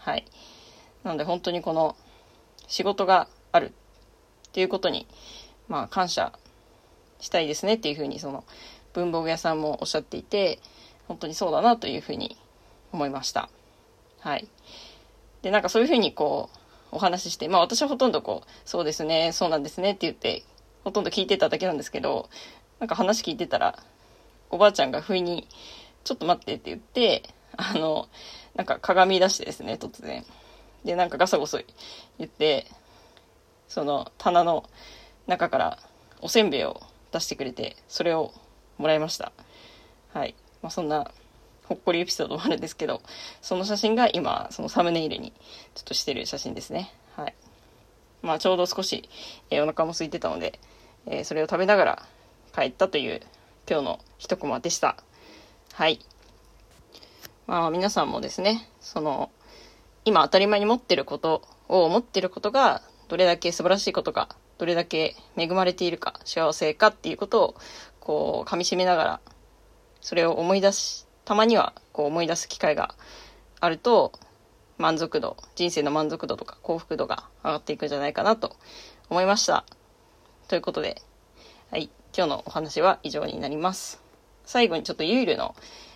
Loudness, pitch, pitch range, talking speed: -26 LUFS, 180 Hz, 160-200 Hz, 330 characters per minute